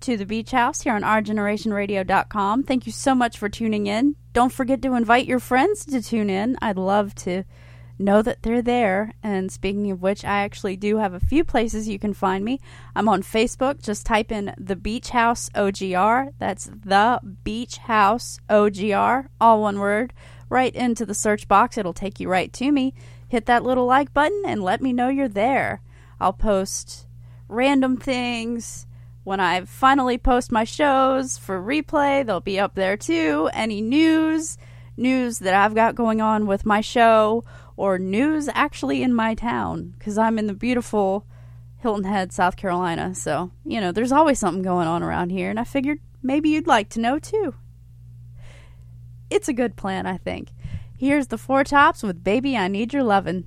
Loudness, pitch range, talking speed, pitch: -21 LUFS, 190-255 Hz, 185 wpm, 220 Hz